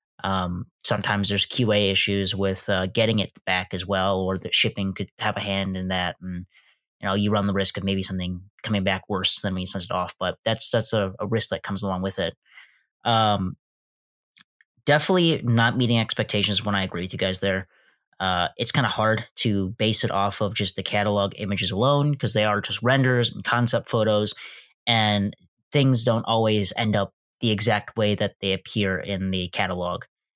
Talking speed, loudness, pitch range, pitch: 200 wpm, -23 LUFS, 95-110 Hz, 100 Hz